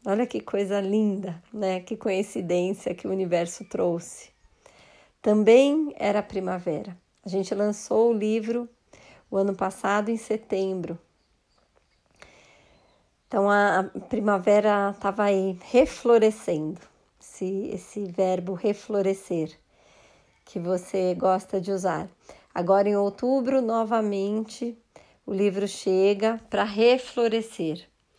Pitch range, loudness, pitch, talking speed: 190-220 Hz, -25 LUFS, 200 Hz, 105 wpm